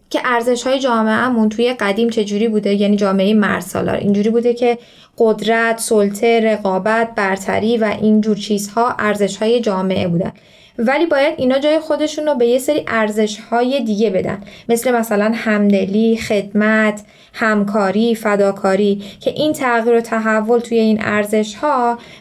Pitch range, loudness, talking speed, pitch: 210-235 Hz, -16 LUFS, 145 wpm, 220 Hz